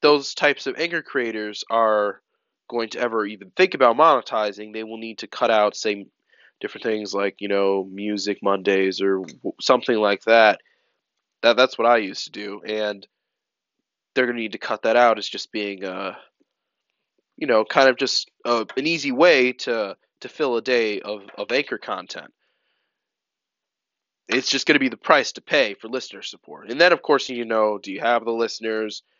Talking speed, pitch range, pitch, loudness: 190 wpm, 100-120 Hz, 110 Hz, -21 LUFS